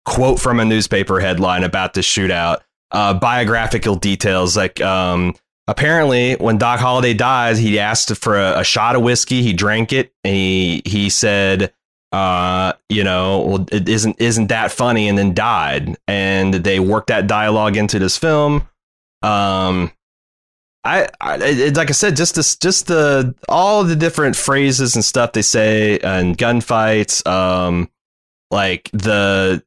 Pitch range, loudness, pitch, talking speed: 95-125 Hz, -15 LUFS, 105 Hz, 160 wpm